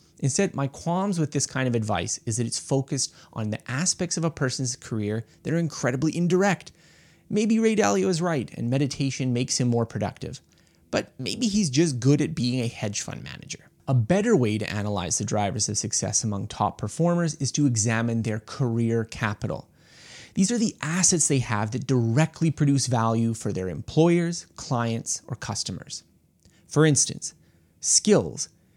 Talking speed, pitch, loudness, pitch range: 170 wpm, 135 Hz, -25 LUFS, 115-165 Hz